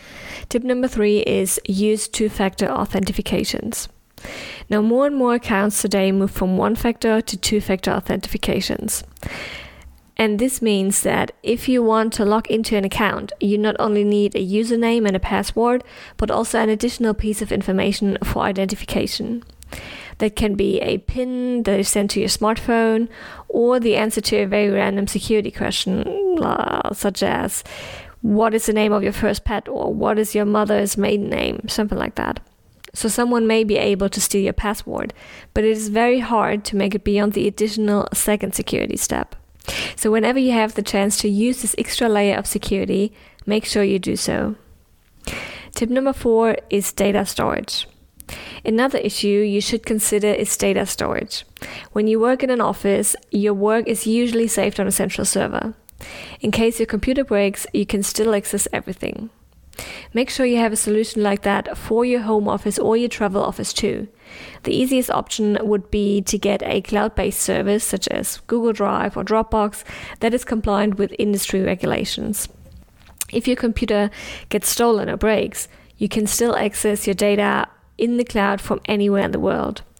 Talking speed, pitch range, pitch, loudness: 175 wpm, 200-225 Hz, 210 Hz, -20 LUFS